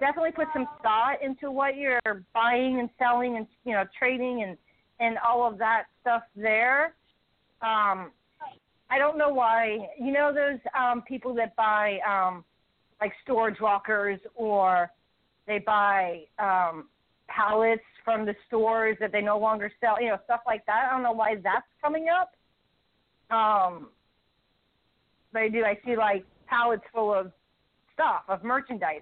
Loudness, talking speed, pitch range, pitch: -26 LUFS, 155 wpm, 210-250 Hz, 225 Hz